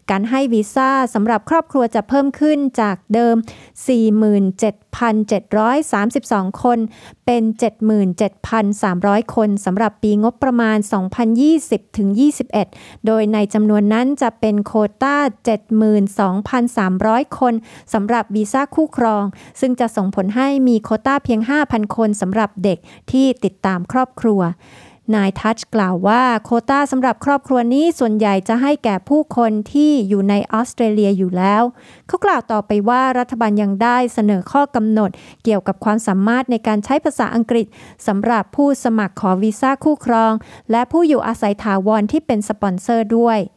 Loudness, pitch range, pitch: -16 LUFS, 210-250 Hz, 225 Hz